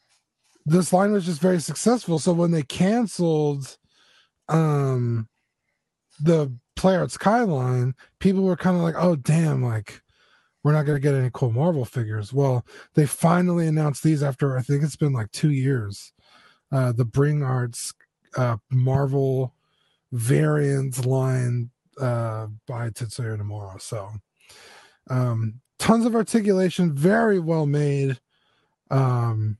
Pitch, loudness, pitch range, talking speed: 140 Hz, -23 LUFS, 125-165 Hz, 130 wpm